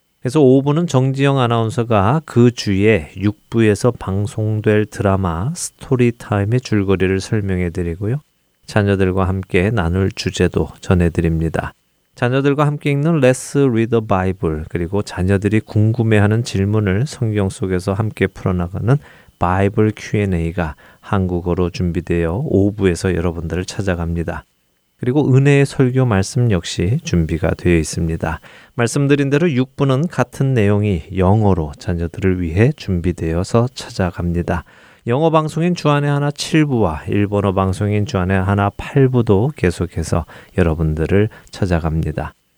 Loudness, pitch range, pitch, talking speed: -17 LUFS, 90-120 Hz, 100 Hz, 325 characters per minute